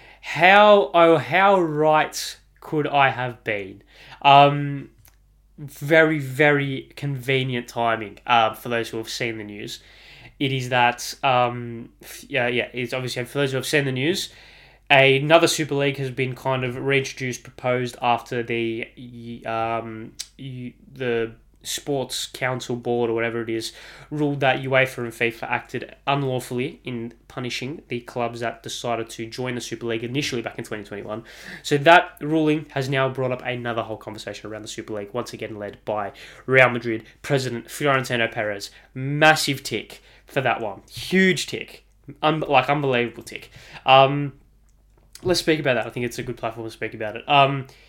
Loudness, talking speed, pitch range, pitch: -21 LUFS, 160 wpm, 115-140 Hz, 125 Hz